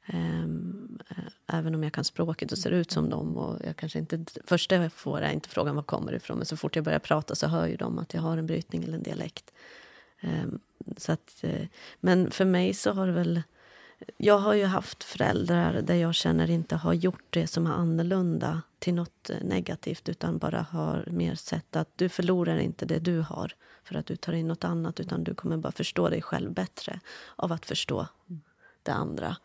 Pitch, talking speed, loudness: 165 Hz, 205 wpm, -29 LUFS